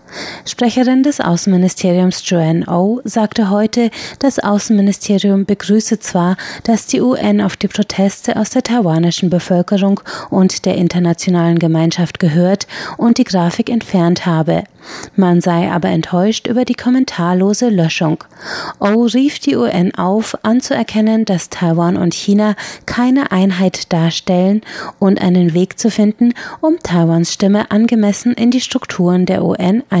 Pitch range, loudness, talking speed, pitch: 180-225 Hz, -14 LUFS, 140 wpm, 200 Hz